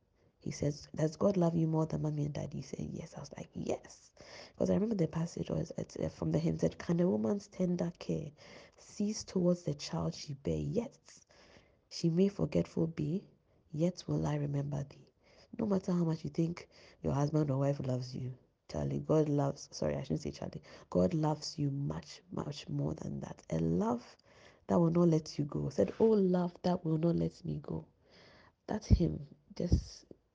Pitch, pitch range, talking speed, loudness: 155 Hz, 130-175 Hz, 195 wpm, -35 LUFS